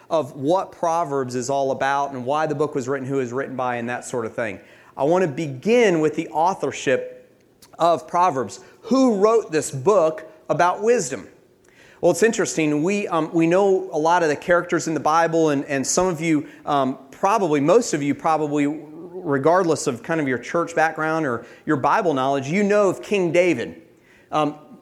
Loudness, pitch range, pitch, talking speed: -21 LUFS, 140-175 Hz, 155 Hz, 195 wpm